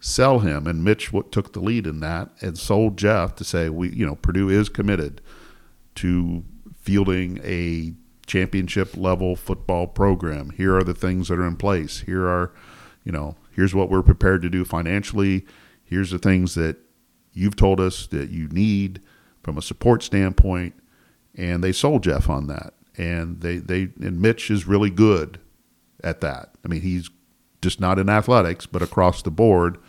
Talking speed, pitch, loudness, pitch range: 175 wpm, 95 Hz, -22 LUFS, 85-100 Hz